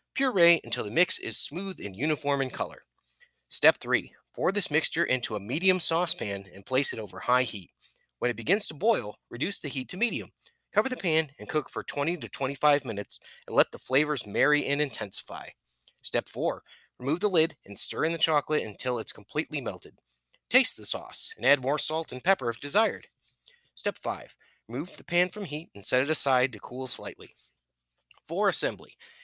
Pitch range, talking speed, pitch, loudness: 125-170 Hz, 190 wpm, 150 Hz, -28 LUFS